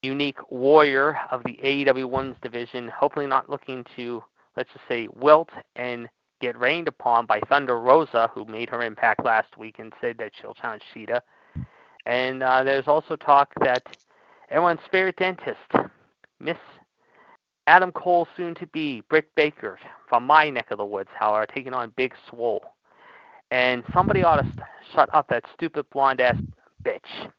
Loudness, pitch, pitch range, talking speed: -23 LUFS, 135 Hz, 125-165 Hz, 160 wpm